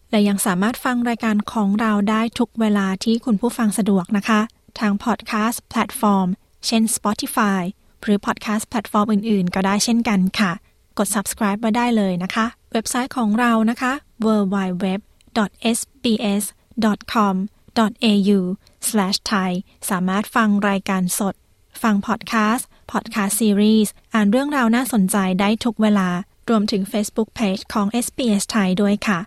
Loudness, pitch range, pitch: -20 LUFS, 200-230 Hz, 215 Hz